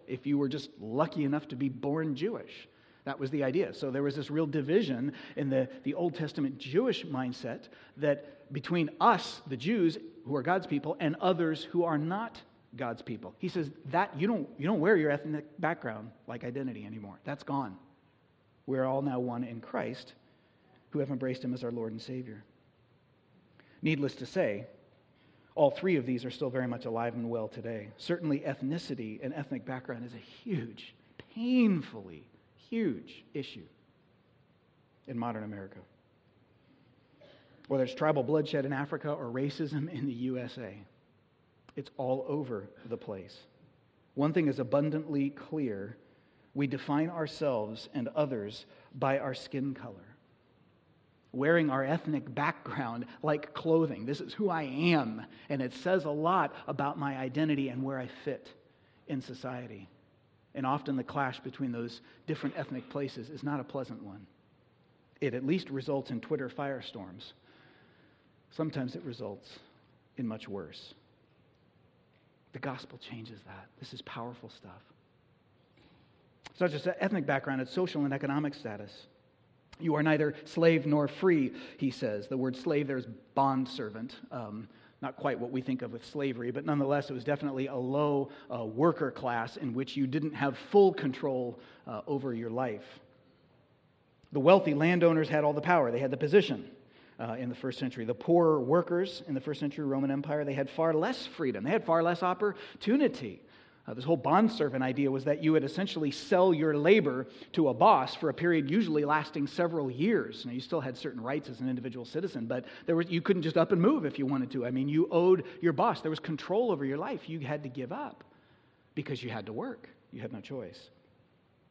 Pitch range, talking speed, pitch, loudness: 125-155 Hz, 175 wpm, 140 Hz, -32 LUFS